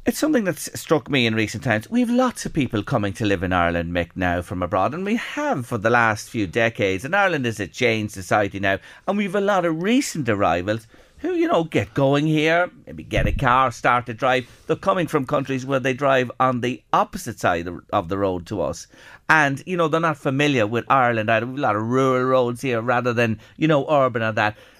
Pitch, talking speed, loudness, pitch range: 125 Hz, 225 wpm, -21 LUFS, 110-155 Hz